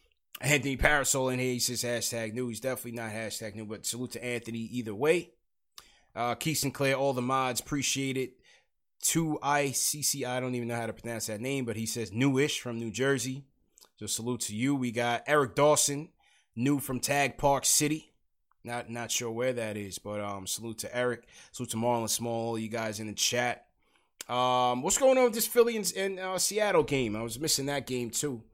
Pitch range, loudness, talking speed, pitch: 115-140 Hz, -29 LUFS, 200 wpm, 125 Hz